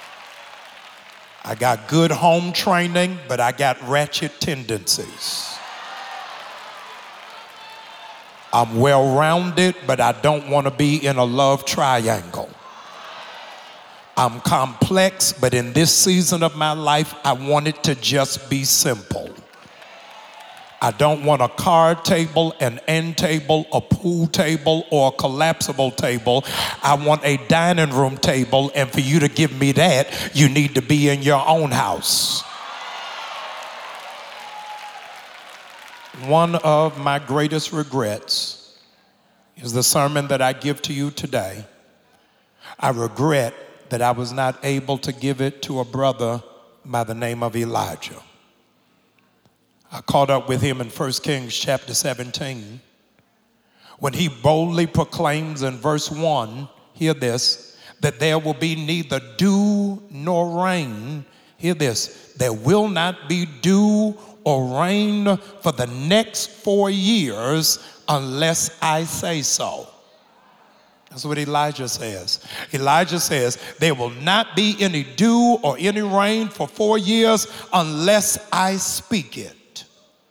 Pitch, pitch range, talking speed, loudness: 150 Hz, 135-170 Hz, 130 wpm, -19 LUFS